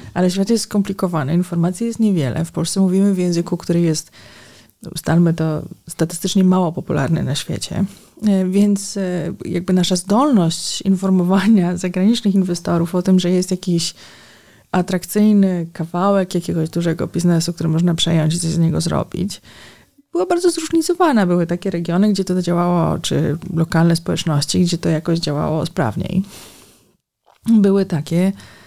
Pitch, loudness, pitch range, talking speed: 175 Hz, -18 LUFS, 165-195 Hz, 135 wpm